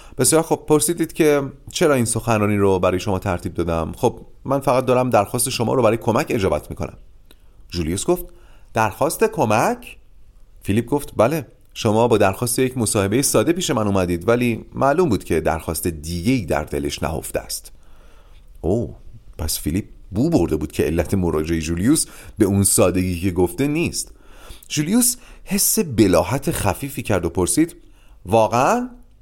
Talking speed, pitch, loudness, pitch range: 150 wpm, 110 Hz, -19 LUFS, 90-140 Hz